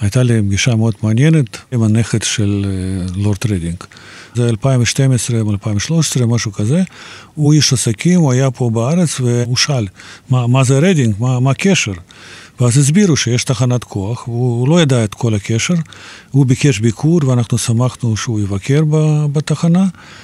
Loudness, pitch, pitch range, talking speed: -14 LUFS, 125 Hz, 110-145 Hz, 145 wpm